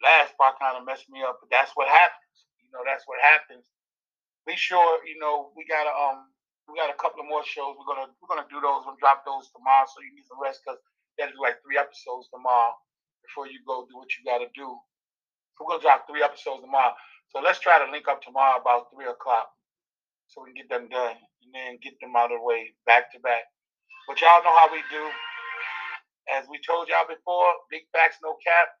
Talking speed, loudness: 225 wpm, -23 LUFS